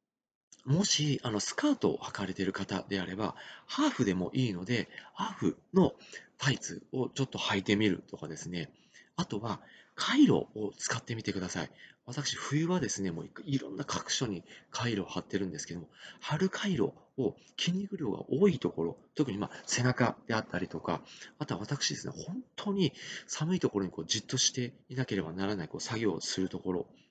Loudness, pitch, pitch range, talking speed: -33 LUFS, 120 Hz, 95-145 Hz, 365 characters per minute